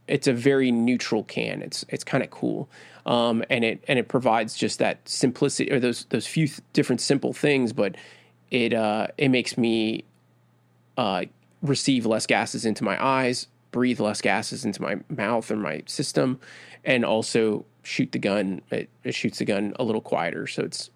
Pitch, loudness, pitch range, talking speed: 120 Hz, -25 LUFS, 105-130 Hz, 185 wpm